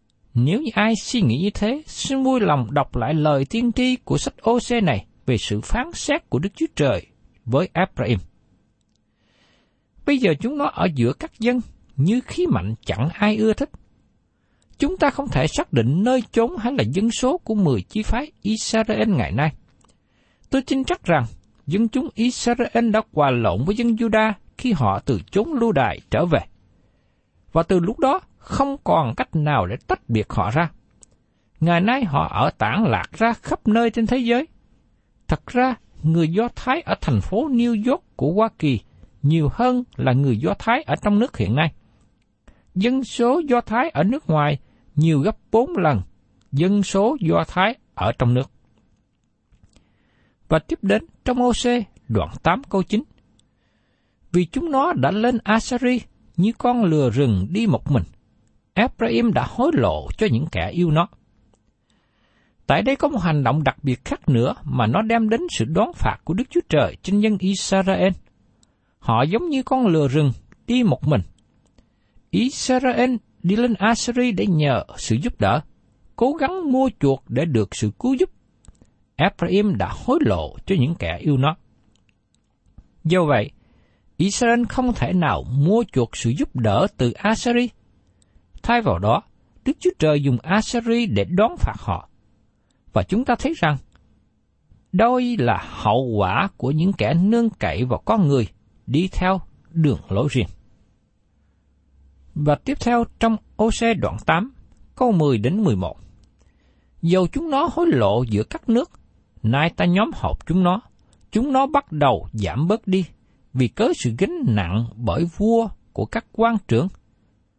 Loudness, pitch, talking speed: -21 LUFS, 170 Hz, 170 wpm